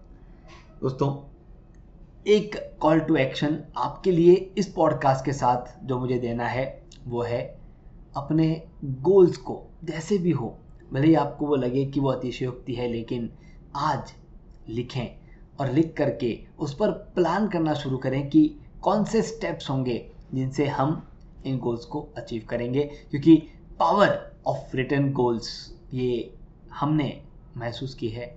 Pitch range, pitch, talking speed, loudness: 130-160 Hz, 145 Hz, 140 wpm, -25 LUFS